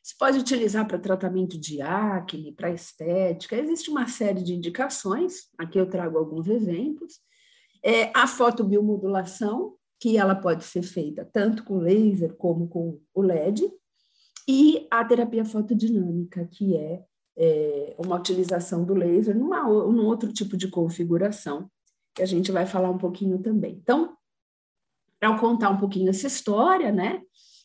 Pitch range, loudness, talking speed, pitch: 180-230 Hz, -24 LUFS, 145 wpm, 195 Hz